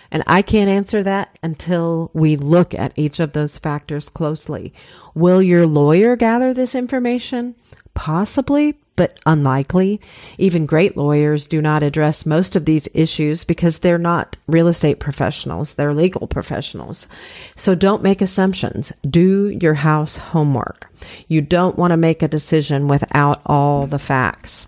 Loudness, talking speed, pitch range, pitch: -17 LUFS, 150 wpm, 150-190 Hz, 160 Hz